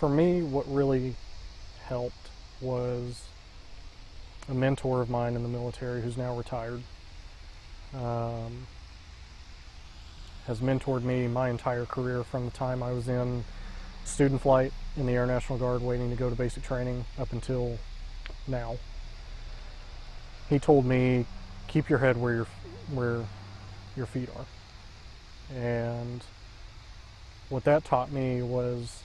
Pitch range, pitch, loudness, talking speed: 95-125 Hz, 120 Hz, -30 LUFS, 130 wpm